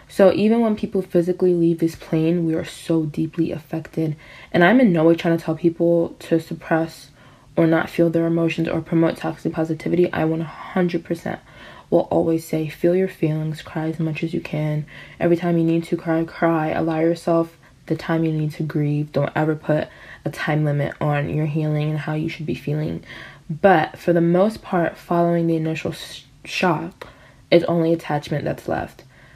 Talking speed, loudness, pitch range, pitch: 185 wpm, -21 LUFS, 155-170 Hz, 165 Hz